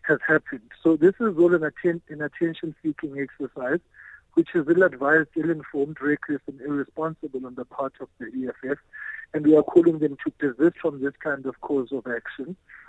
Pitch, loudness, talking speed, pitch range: 155 Hz, -24 LUFS, 190 wpm, 140-170 Hz